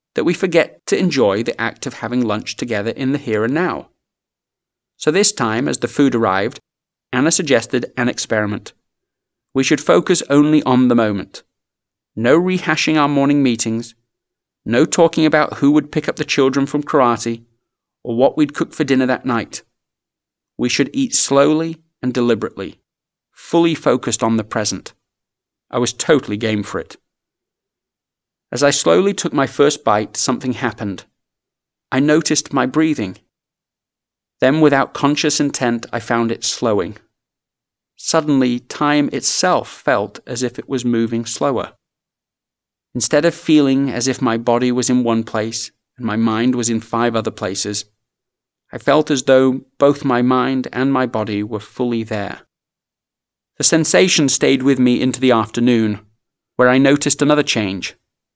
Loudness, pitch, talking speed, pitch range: -16 LUFS, 130 Hz, 155 wpm, 115-145 Hz